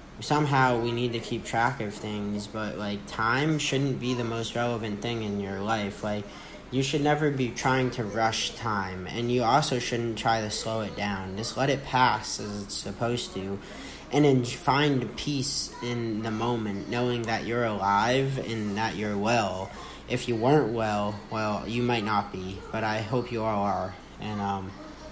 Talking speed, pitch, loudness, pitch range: 185 wpm, 115 Hz, -28 LUFS, 105-125 Hz